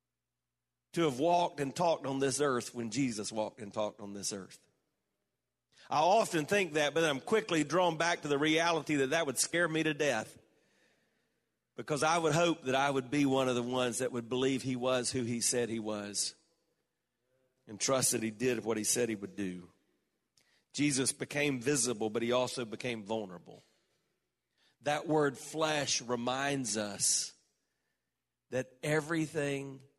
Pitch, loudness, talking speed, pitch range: 135 Hz, -32 LUFS, 170 wpm, 120-155 Hz